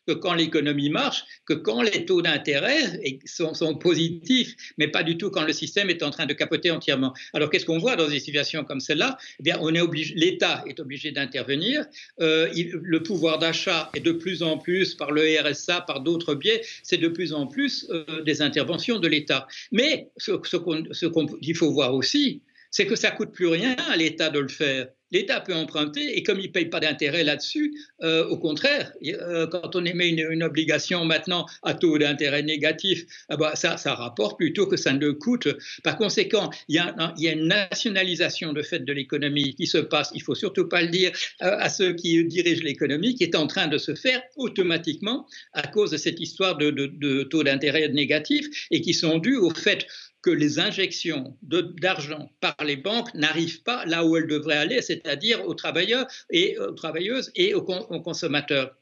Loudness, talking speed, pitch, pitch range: -24 LUFS, 205 wpm, 165 Hz, 150-185 Hz